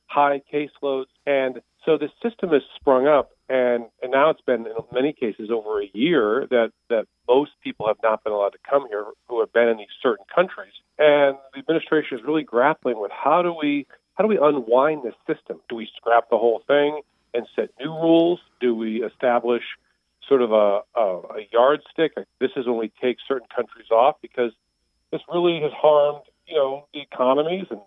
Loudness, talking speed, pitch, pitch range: -22 LUFS, 195 wpm, 140 Hz, 120-160 Hz